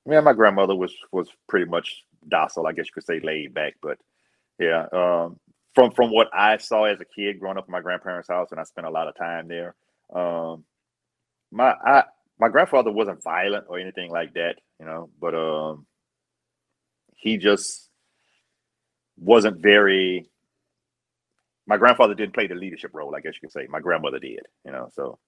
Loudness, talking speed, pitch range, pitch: -22 LUFS, 185 wpm, 85-105 Hz, 90 Hz